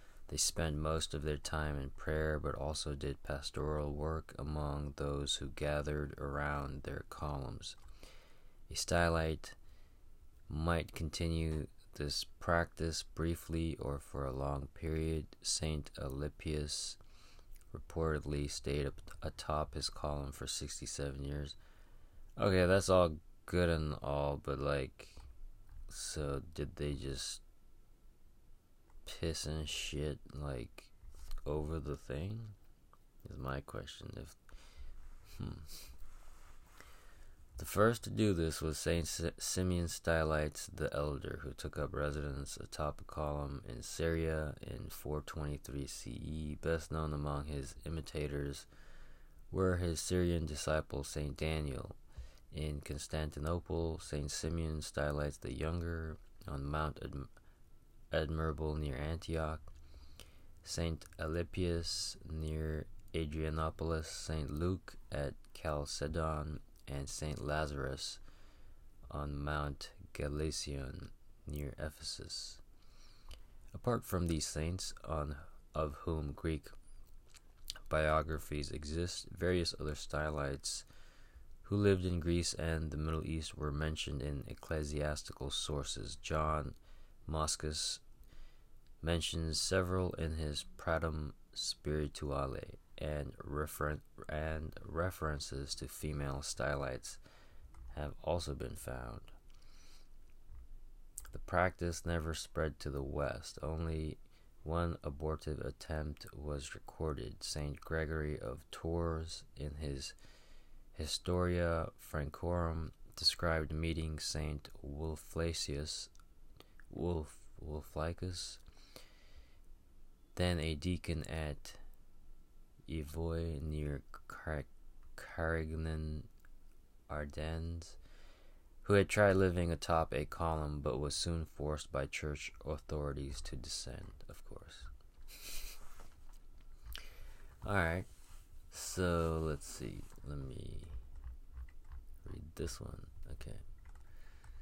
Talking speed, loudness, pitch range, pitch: 100 wpm, -39 LUFS, 70-85 Hz, 75 Hz